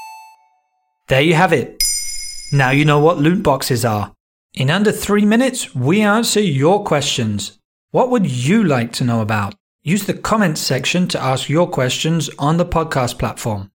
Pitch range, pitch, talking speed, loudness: 130-205 Hz, 150 Hz, 165 wpm, -16 LUFS